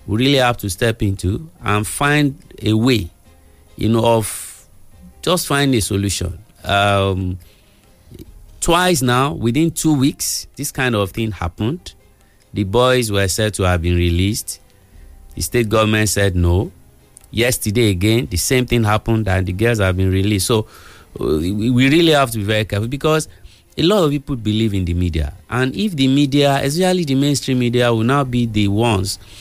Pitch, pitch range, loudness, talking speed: 110 Hz, 95-130 Hz, -17 LUFS, 170 wpm